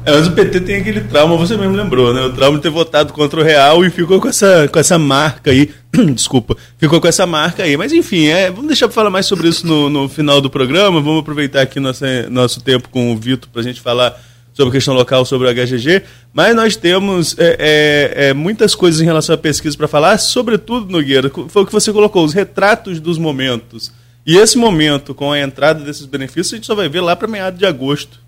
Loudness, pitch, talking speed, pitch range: -12 LUFS, 155 Hz, 235 wpm, 135-185 Hz